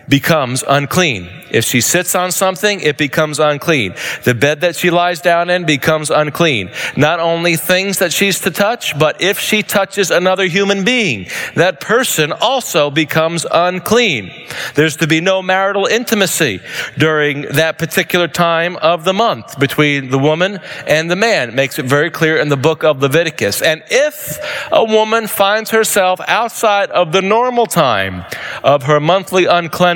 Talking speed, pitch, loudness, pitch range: 165 wpm, 170 Hz, -13 LUFS, 150-195 Hz